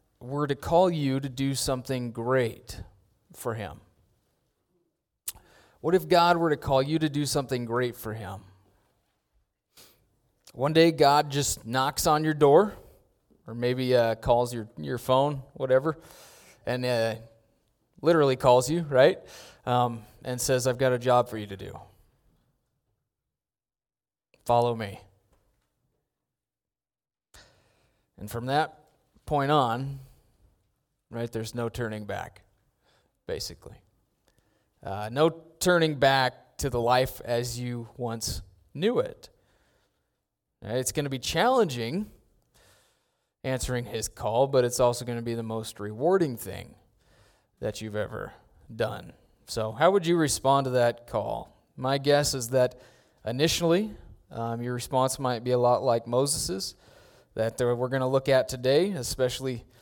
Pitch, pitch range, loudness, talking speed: 125 Hz, 115-140 Hz, -26 LUFS, 135 wpm